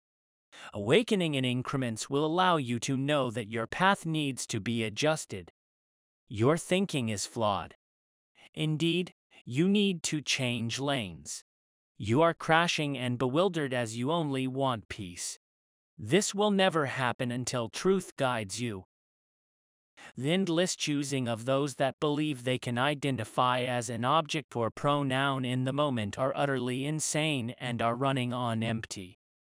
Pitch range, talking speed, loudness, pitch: 115-155 Hz, 140 wpm, -30 LUFS, 130 Hz